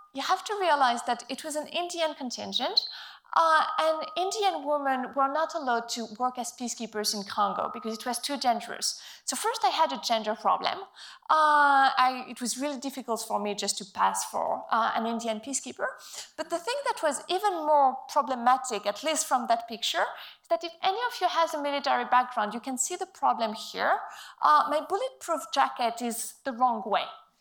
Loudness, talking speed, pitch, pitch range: -28 LUFS, 195 wpm, 270 Hz, 240-325 Hz